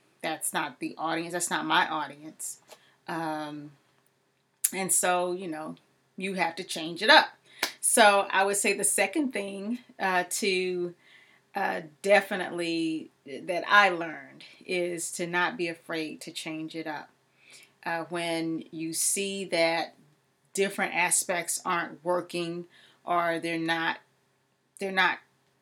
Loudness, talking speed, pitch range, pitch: -27 LUFS, 130 wpm, 160-195 Hz, 175 Hz